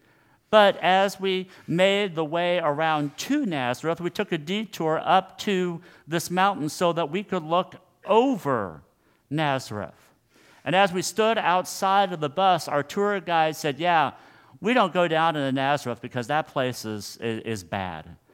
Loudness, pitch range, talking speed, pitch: -24 LUFS, 140-190 Hz, 160 wpm, 170 Hz